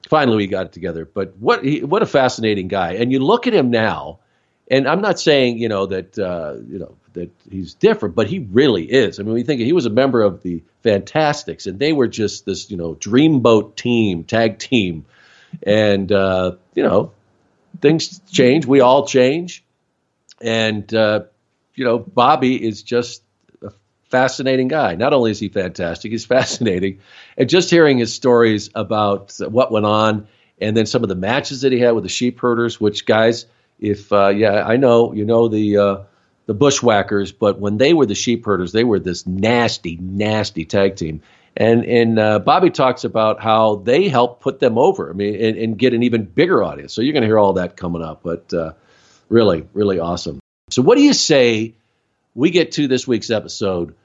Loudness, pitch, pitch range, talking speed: -16 LUFS, 110 Hz, 100-120 Hz, 195 wpm